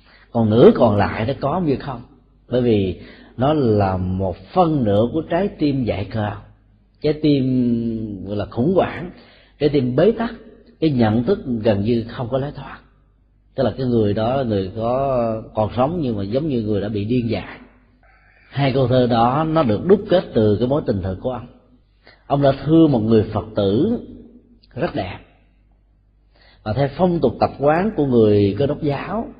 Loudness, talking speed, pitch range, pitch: -19 LUFS, 190 wpm, 105-140 Hz, 120 Hz